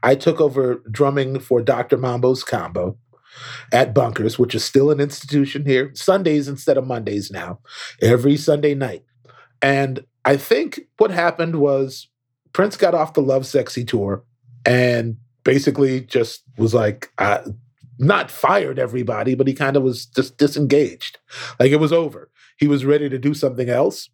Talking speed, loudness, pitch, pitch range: 160 wpm, -19 LUFS, 135 Hz, 125-145 Hz